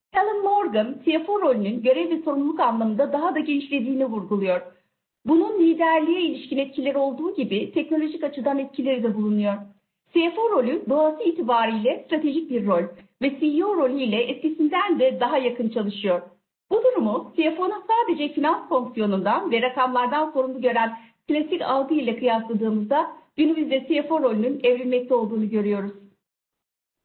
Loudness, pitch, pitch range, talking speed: -23 LUFS, 275 Hz, 230-320 Hz, 130 wpm